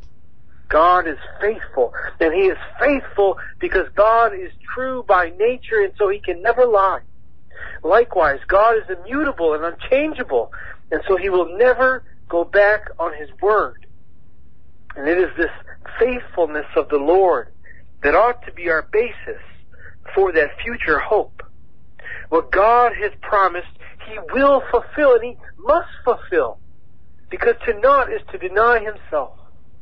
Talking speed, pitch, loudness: 145 wpm, 235 Hz, -18 LUFS